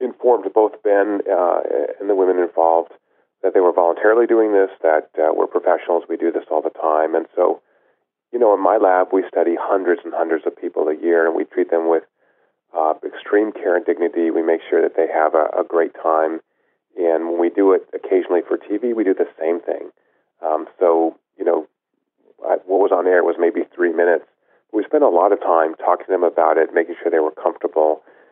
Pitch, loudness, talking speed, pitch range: 85 Hz, -18 LUFS, 215 wpm, 80-105 Hz